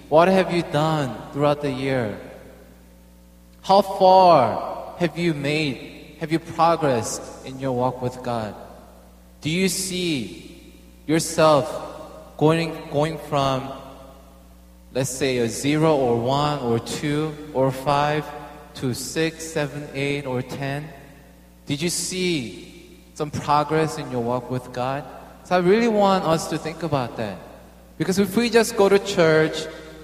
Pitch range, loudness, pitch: 125-160 Hz, -22 LUFS, 145 Hz